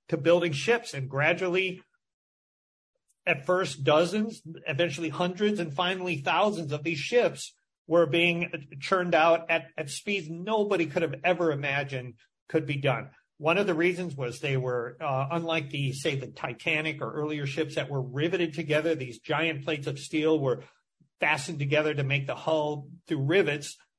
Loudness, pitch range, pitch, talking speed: -28 LUFS, 145-175 Hz, 160 Hz, 165 wpm